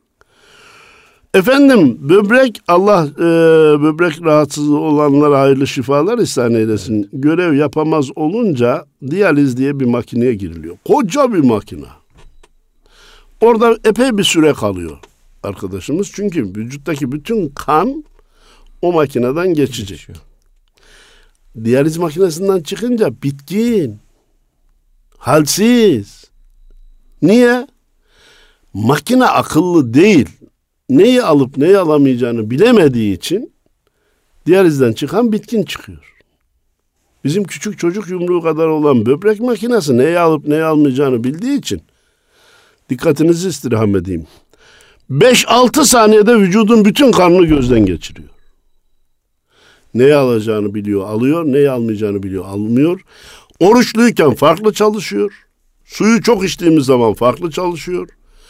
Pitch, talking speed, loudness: 155 Hz, 100 wpm, -12 LUFS